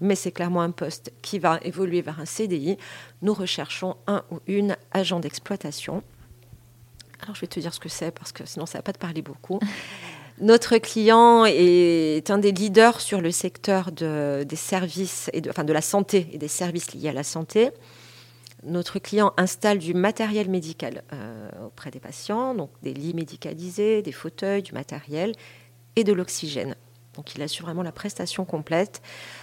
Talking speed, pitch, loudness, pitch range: 180 wpm, 175 Hz, -24 LUFS, 150-200 Hz